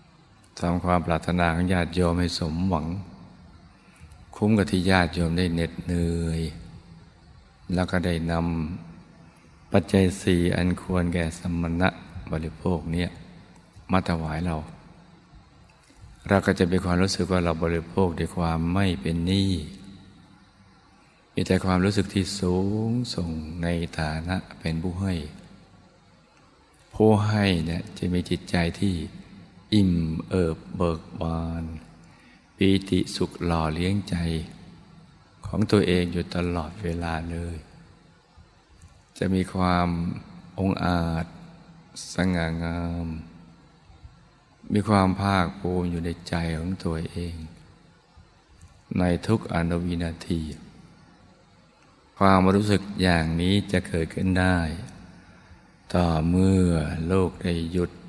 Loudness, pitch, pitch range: -25 LUFS, 90 Hz, 85-95 Hz